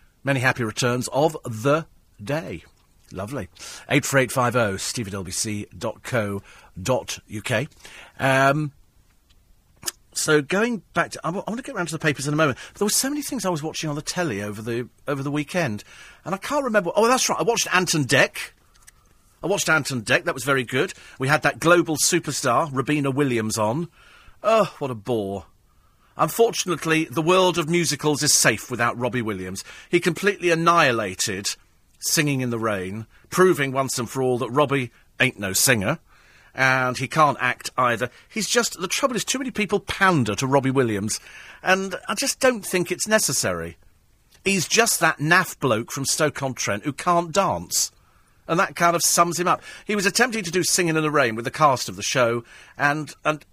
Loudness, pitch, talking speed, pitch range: -22 LUFS, 145 Hz, 175 wpm, 120-175 Hz